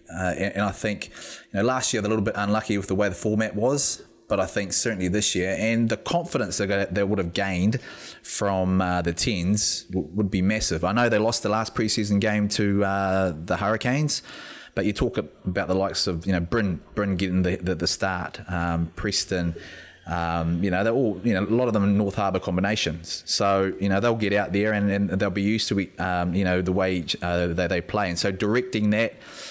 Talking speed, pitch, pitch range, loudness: 235 wpm, 100 Hz, 90-105 Hz, -24 LUFS